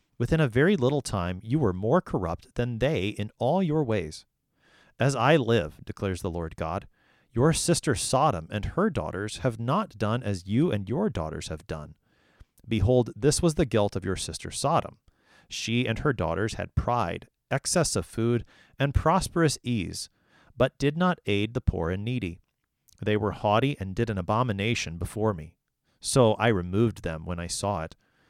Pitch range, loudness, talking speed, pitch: 95-130 Hz, -27 LUFS, 180 wpm, 110 Hz